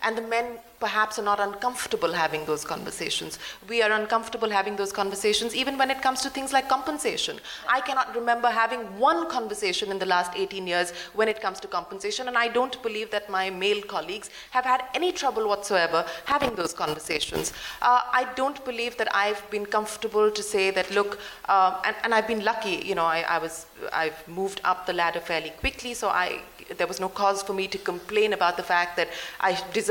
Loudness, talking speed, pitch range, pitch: -26 LUFS, 205 wpm, 185-235 Hz, 210 Hz